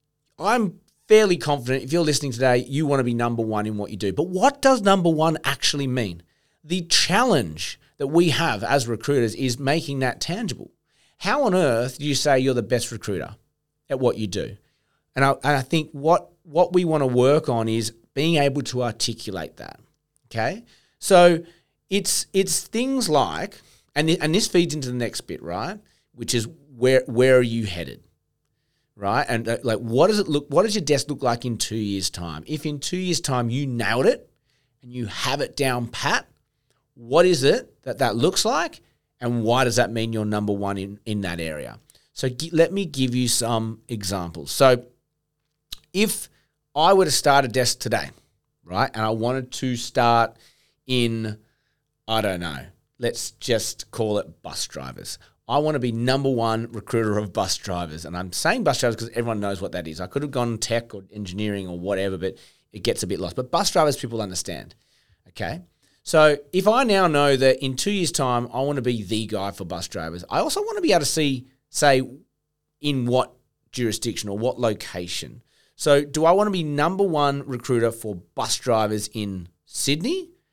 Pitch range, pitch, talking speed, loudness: 115-150 Hz, 130 Hz, 195 wpm, -22 LUFS